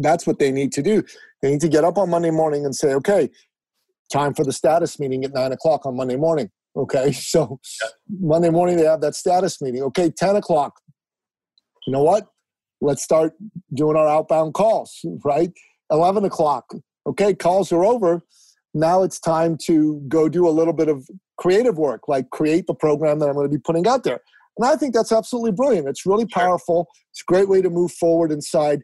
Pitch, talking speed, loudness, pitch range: 165 Hz, 200 wpm, -19 LUFS, 150-180 Hz